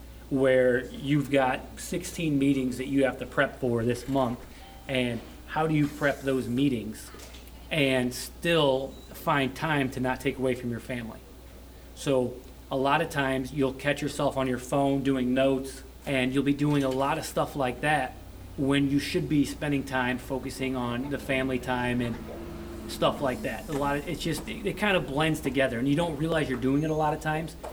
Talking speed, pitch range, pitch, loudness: 195 wpm, 125-145 Hz, 135 Hz, -28 LUFS